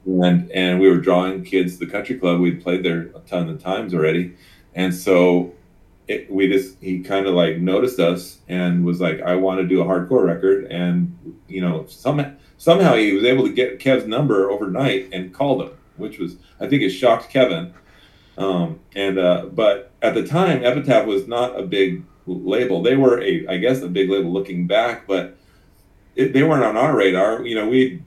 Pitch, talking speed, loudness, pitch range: 95 Hz, 205 wpm, -19 LUFS, 90-110 Hz